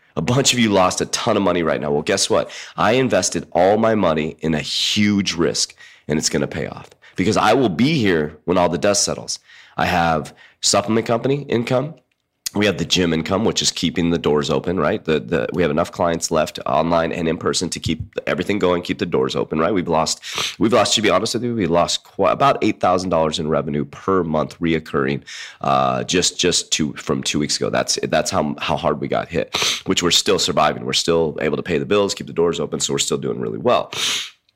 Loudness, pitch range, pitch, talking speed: -19 LUFS, 80-105 Hz, 90 Hz, 235 wpm